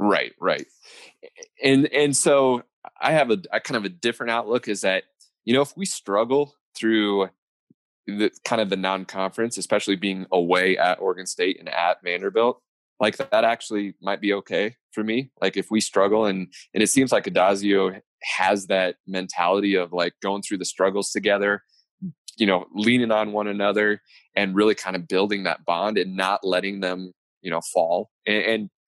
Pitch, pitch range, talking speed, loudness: 100 Hz, 95-115 Hz, 185 wpm, -23 LUFS